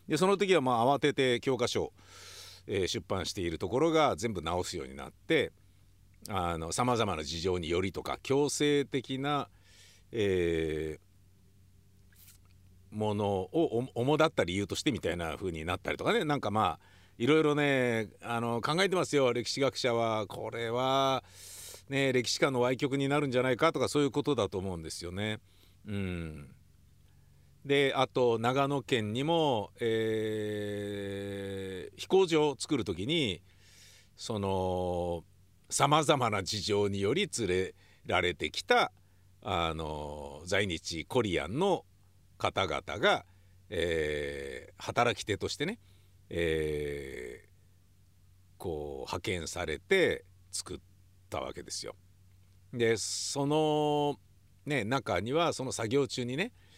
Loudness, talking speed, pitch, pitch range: -31 LUFS, 245 characters per minute, 100 Hz, 95-130 Hz